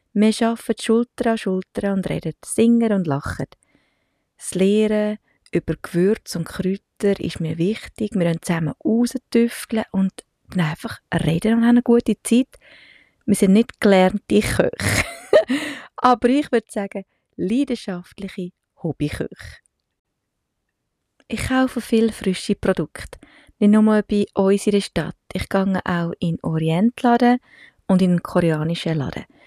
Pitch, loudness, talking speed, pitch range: 205 Hz, -20 LUFS, 130 wpm, 180-230 Hz